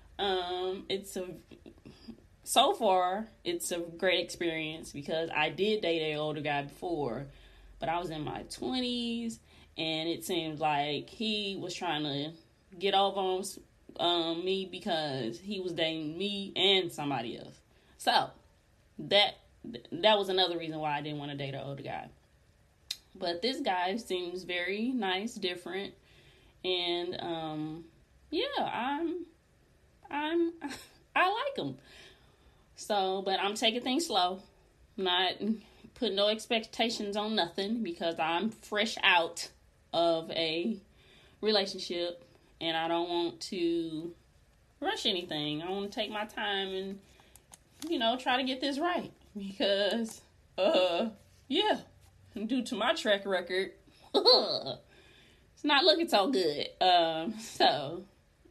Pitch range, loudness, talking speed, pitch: 165-220 Hz, -31 LUFS, 135 wpm, 190 Hz